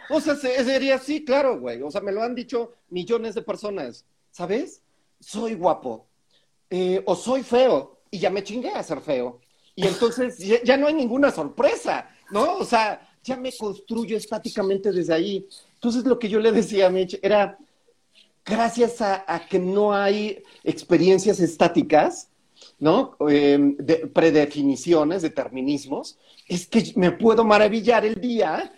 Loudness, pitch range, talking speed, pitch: -22 LUFS, 180-235 Hz, 155 wpm, 205 Hz